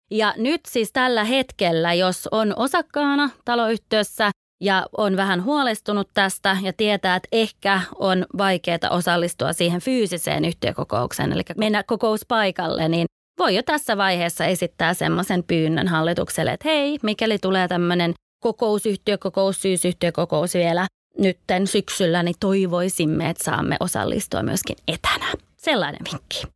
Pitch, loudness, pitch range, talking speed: 195 Hz, -21 LUFS, 175-220 Hz, 125 wpm